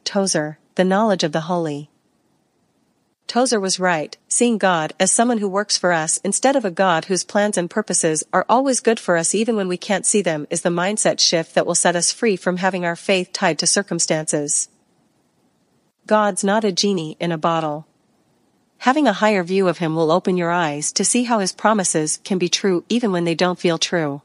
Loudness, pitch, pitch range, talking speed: -18 LUFS, 185 Hz, 170-205 Hz, 205 wpm